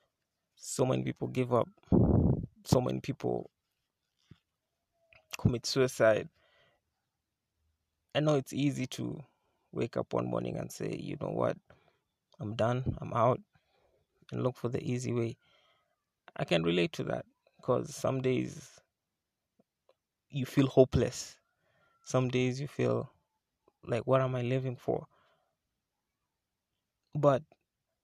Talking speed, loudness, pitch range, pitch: 120 wpm, -32 LUFS, 85-130 Hz, 120 Hz